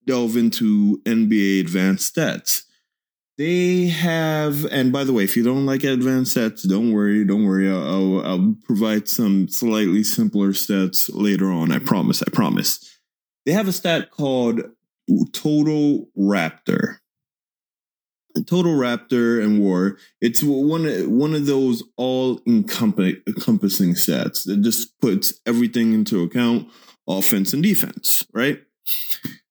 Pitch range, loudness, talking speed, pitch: 100-145 Hz, -19 LUFS, 130 wpm, 120 Hz